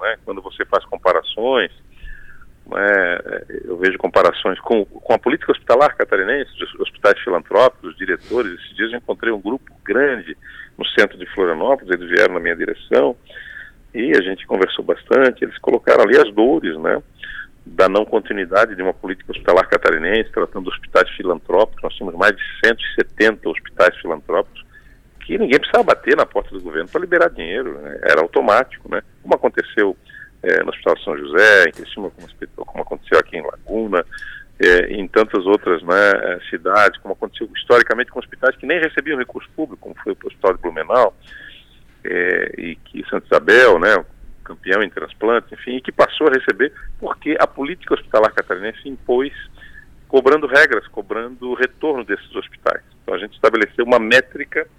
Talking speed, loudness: 165 wpm, -17 LUFS